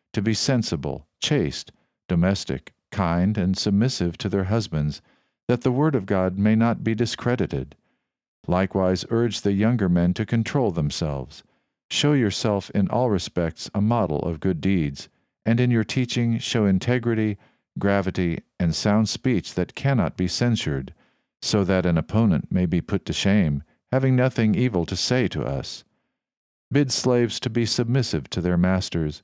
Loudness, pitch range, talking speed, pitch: -23 LUFS, 90-115 Hz, 155 wpm, 100 Hz